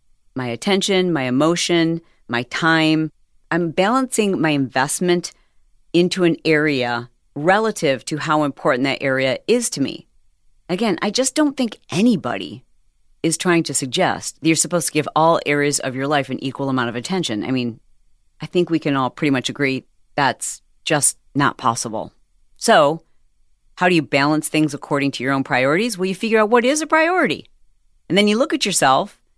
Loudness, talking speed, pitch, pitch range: -19 LUFS, 175 wpm, 155 Hz, 130-185 Hz